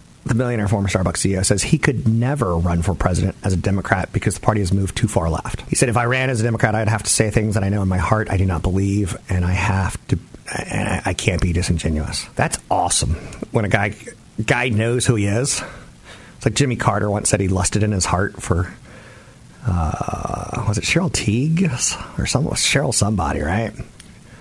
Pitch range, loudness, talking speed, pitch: 95-120 Hz, -19 LUFS, 215 wpm, 105 Hz